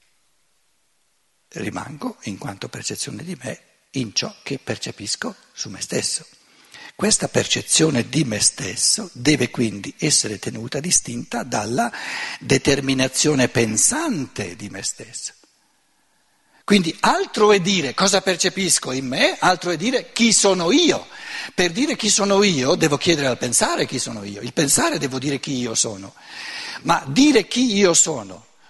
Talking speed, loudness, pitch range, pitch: 140 wpm, -19 LUFS, 125-200 Hz, 160 Hz